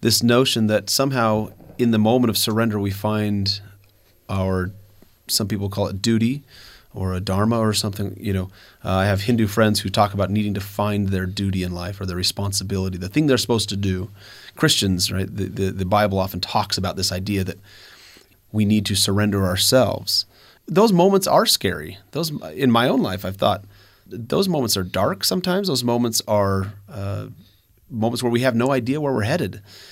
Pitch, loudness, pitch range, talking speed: 100 Hz, -20 LUFS, 95-115 Hz, 180 wpm